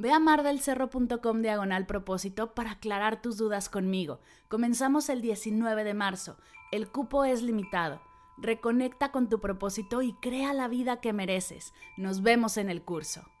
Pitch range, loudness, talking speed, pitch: 195-250 Hz, -30 LUFS, 150 wpm, 220 Hz